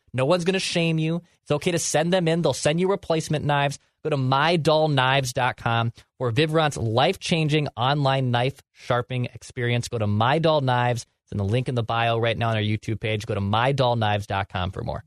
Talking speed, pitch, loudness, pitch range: 195 wpm, 130 Hz, -23 LUFS, 115-155 Hz